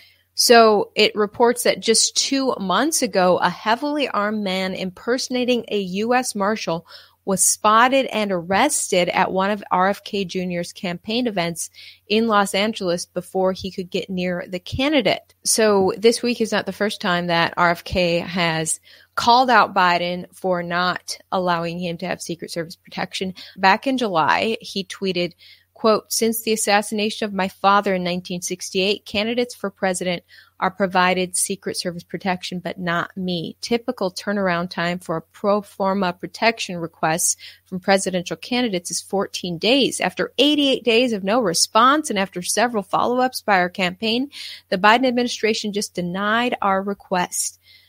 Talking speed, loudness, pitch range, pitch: 150 wpm, -20 LUFS, 180-220 Hz, 195 Hz